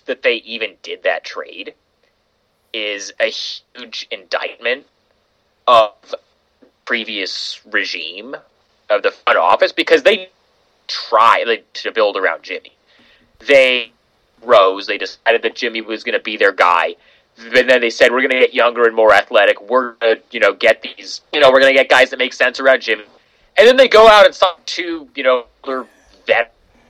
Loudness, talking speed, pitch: -14 LUFS, 170 wpm, 135 Hz